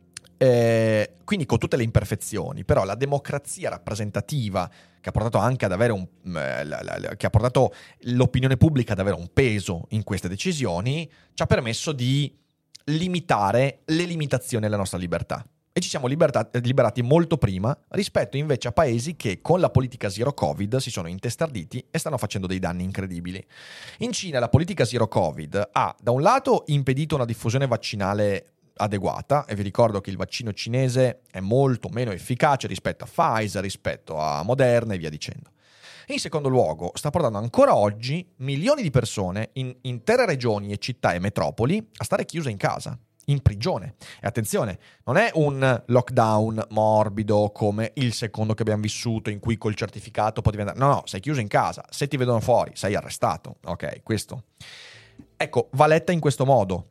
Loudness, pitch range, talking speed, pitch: -24 LUFS, 105-140 Hz, 170 wpm, 120 Hz